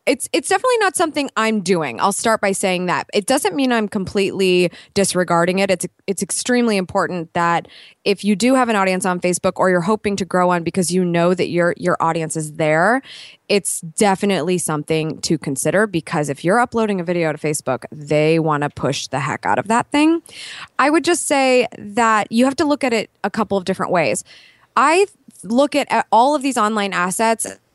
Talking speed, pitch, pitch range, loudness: 200 wpm, 195 Hz, 175-230 Hz, -18 LUFS